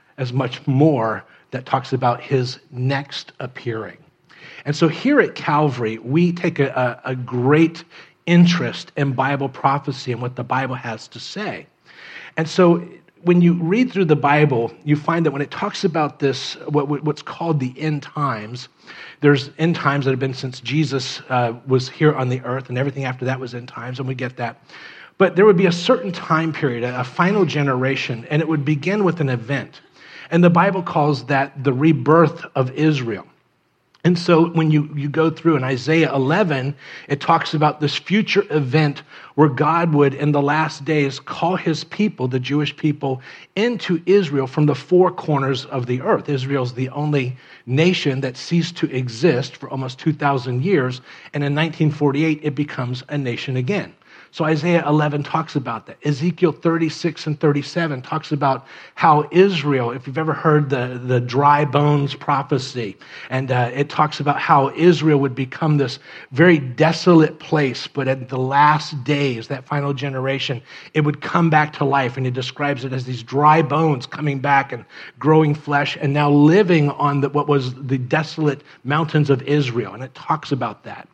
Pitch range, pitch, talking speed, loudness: 130-160 Hz, 145 Hz, 180 wpm, -19 LUFS